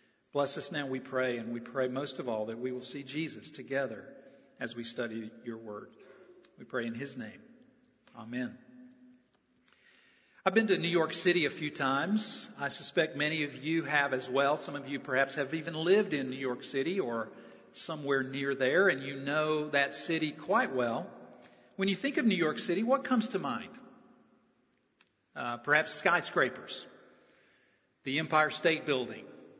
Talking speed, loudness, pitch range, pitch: 170 wpm, -32 LUFS, 130-175 Hz, 145 Hz